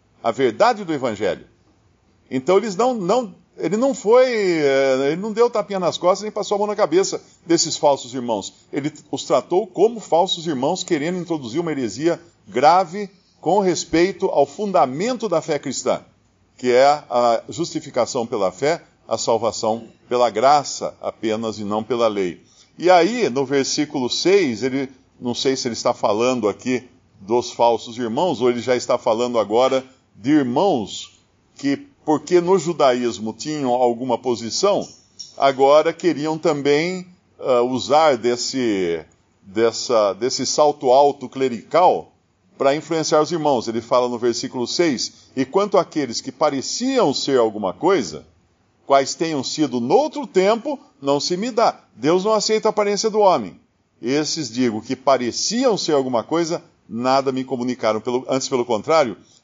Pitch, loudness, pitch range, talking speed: 140 Hz, -20 LUFS, 125-180 Hz, 150 wpm